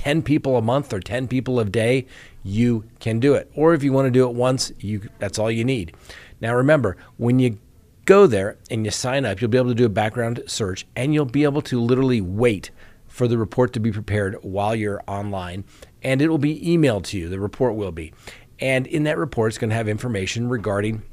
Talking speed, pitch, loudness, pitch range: 225 wpm, 120 Hz, -21 LUFS, 105-130 Hz